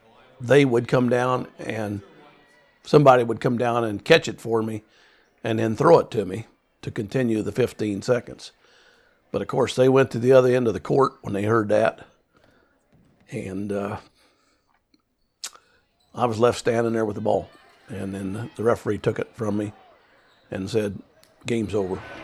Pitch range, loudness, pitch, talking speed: 105-125 Hz, -22 LUFS, 115 Hz, 170 wpm